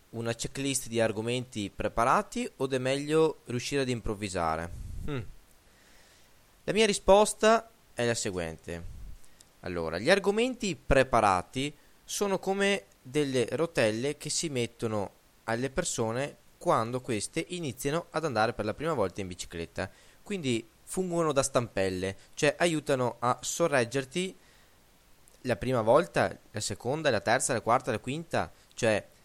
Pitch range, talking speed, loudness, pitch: 105-165 Hz, 125 wpm, -29 LUFS, 125 Hz